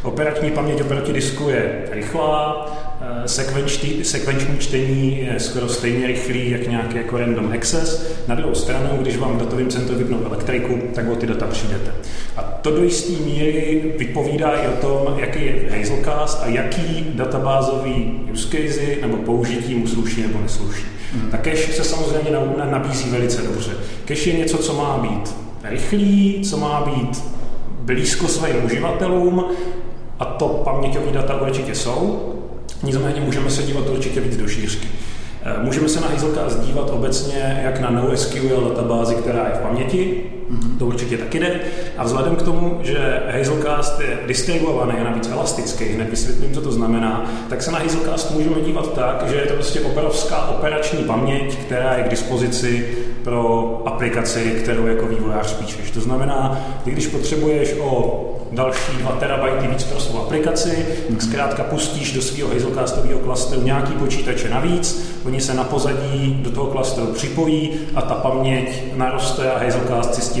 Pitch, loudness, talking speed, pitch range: 130 Hz, -20 LUFS, 160 wpm, 120-150 Hz